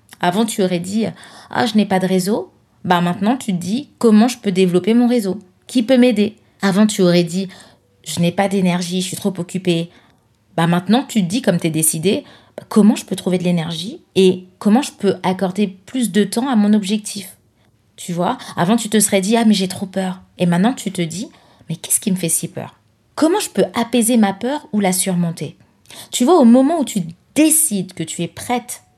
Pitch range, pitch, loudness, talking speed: 175-225 Hz, 195 Hz, -17 LUFS, 225 wpm